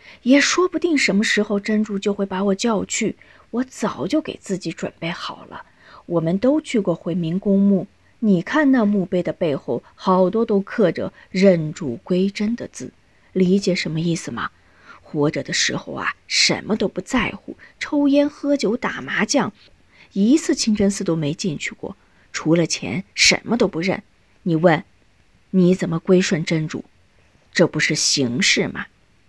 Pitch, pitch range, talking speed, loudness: 195 Hz, 170-225 Hz, 230 characters per minute, -20 LUFS